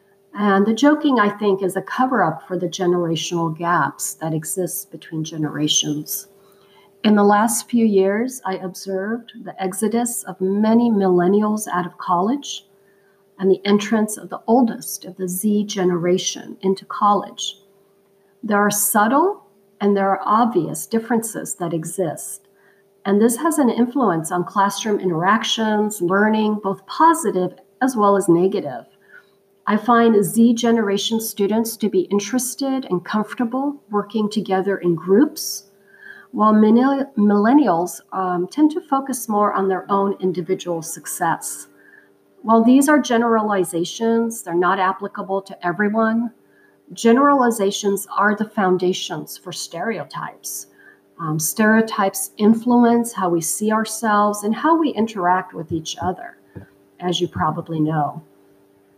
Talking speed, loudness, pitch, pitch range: 130 wpm, -19 LUFS, 200 Hz, 180-225 Hz